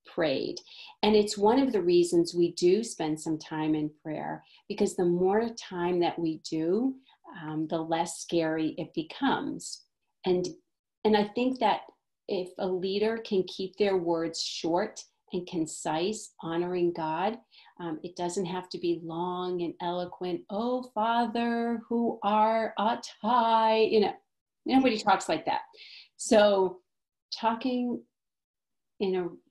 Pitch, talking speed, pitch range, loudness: 190 Hz, 140 wpm, 170-225 Hz, -29 LUFS